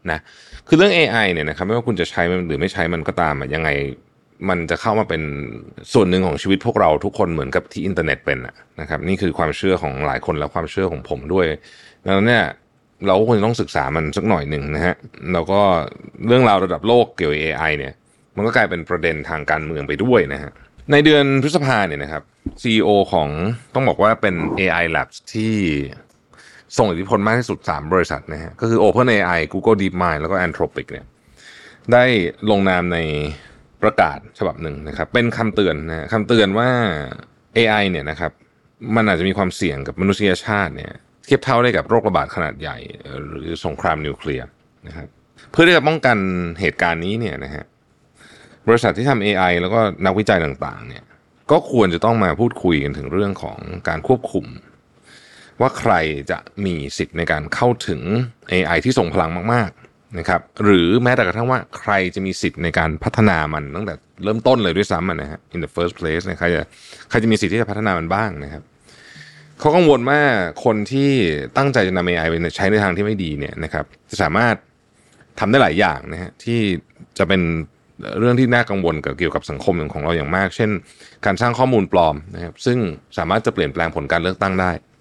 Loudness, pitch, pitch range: -18 LUFS, 95 Hz, 80-110 Hz